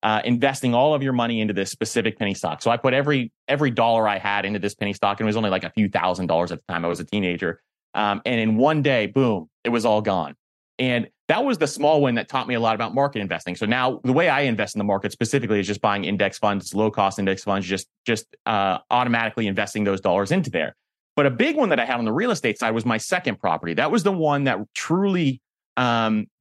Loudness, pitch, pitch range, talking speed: -22 LUFS, 110 Hz, 100-125 Hz, 260 wpm